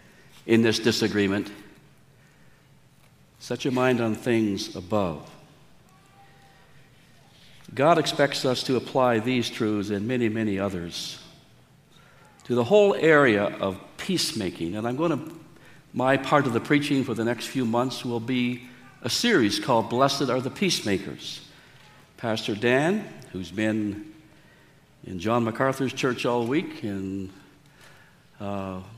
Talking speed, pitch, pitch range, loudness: 125 wpm, 130 Hz, 110-140 Hz, -25 LUFS